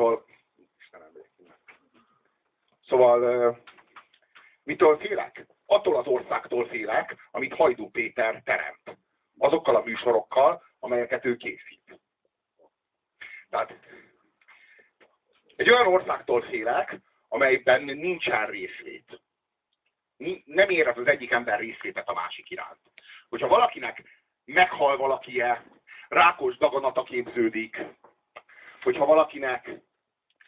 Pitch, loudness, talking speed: 195 Hz, -25 LUFS, 85 wpm